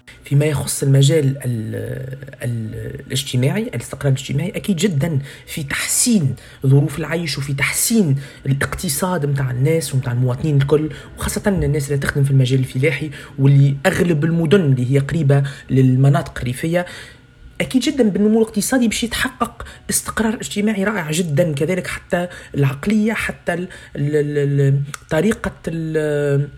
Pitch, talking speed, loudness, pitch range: 145 Hz, 125 wpm, -18 LUFS, 135-180 Hz